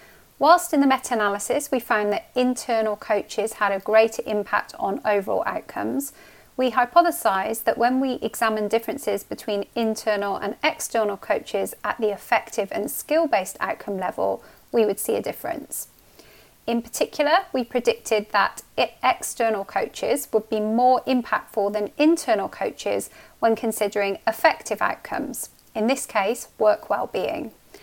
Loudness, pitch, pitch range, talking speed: -23 LUFS, 225 Hz, 210-260 Hz, 135 wpm